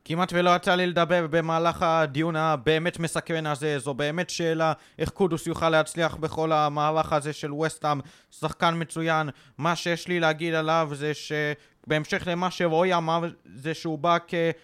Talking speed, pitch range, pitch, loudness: 155 wpm, 155-170 Hz, 160 Hz, -25 LUFS